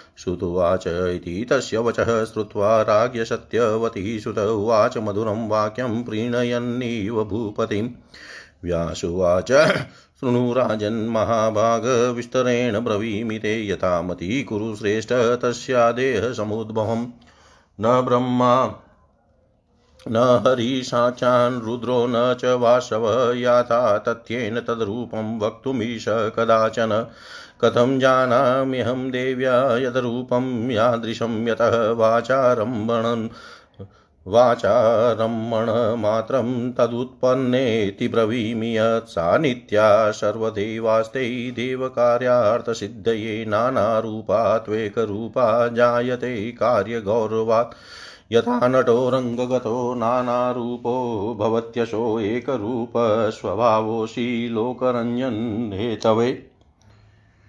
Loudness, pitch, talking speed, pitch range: -21 LUFS, 115 Hz, 55 wpm, 110-125 Hz